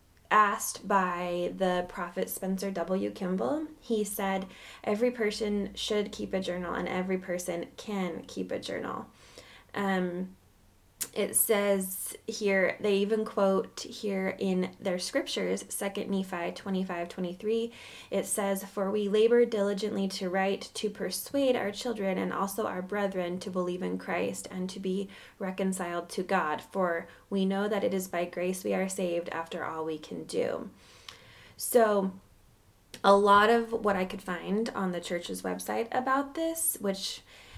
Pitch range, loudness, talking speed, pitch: 180-210 Hz, -30 LUFS, 150 wpm, 195 Hz